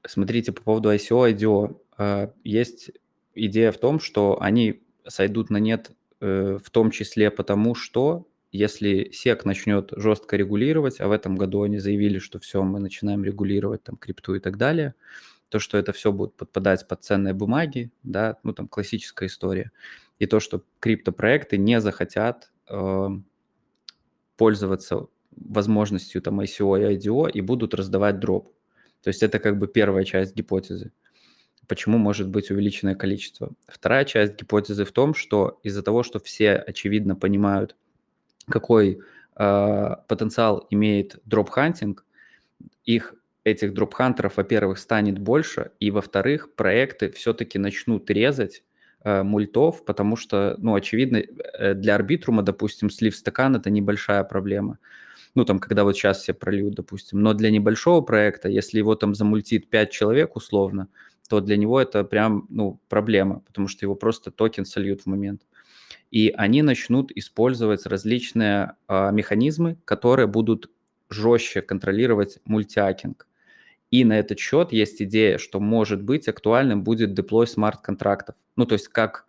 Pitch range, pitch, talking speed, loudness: 100-110 Hz, 105 Hz, 145 wpm, -23 LUFS